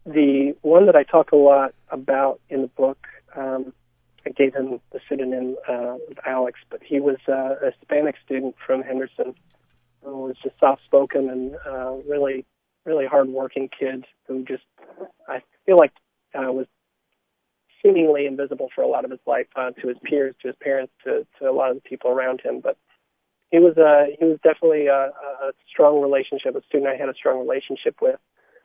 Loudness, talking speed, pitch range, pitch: -21 LUFS, 190 wpm, 130-150 Hz, 135 Hz